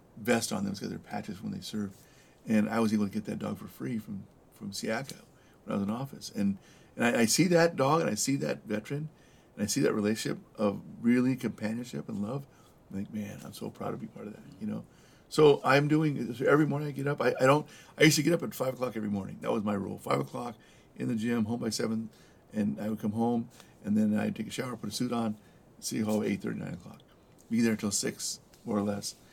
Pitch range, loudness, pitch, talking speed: 105-140 Hz, -30 LUFS, 115 Hz, 255 wpm